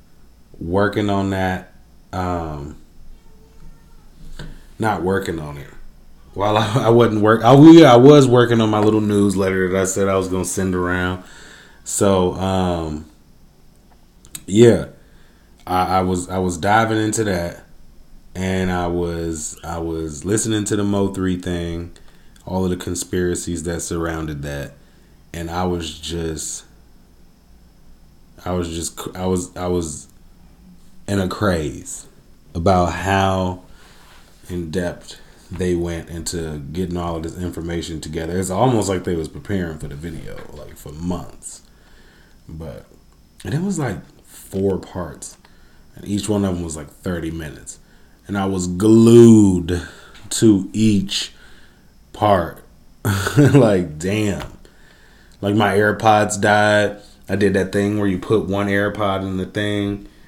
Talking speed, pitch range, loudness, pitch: 140 wpm, 85-100 Hz, -18 LUFS, 95 Hz